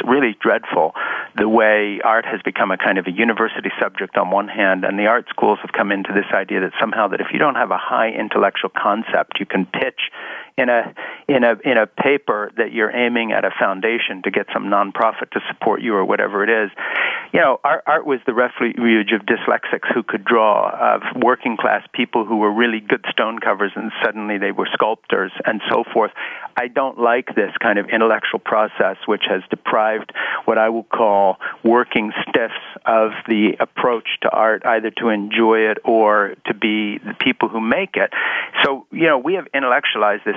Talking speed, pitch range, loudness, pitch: 200 wpm, 105-120 Hz, -18 LUFS, 110 Hz